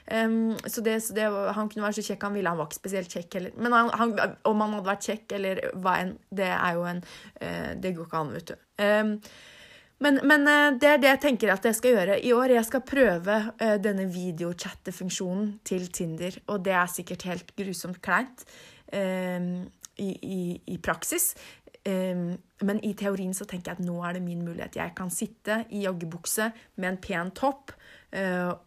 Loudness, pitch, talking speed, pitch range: -27 LUFS, 195 Hz, 205 wpm, 180-220 Hz